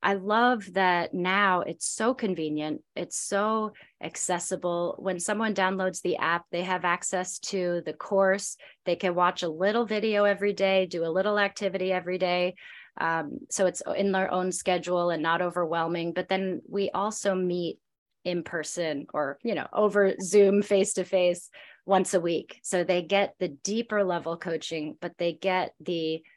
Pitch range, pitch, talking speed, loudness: 175-200 Hz, 185 Hz, 170 wpm, -27 LUFS